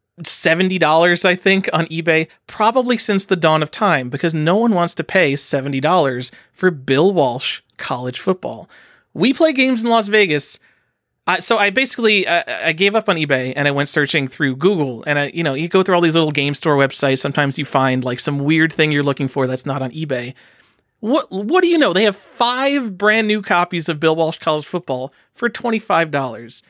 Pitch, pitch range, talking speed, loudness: 165 Hz, 140-200 Hz, 210 wpm, -16 LUFS